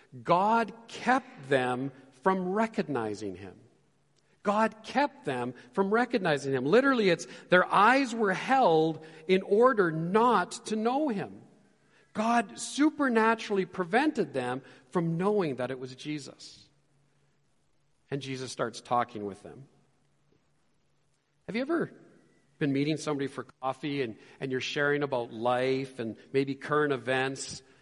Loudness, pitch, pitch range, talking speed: -29 LUFS, 155 Hz, 130-220 Hz, 125 wpm